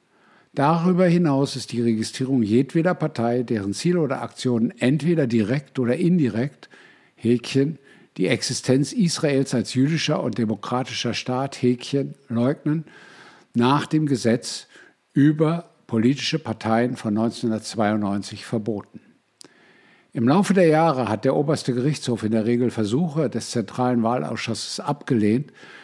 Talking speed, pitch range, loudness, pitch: 120 wpm, 115-145 Hz, -22 LUFS, 125 Hz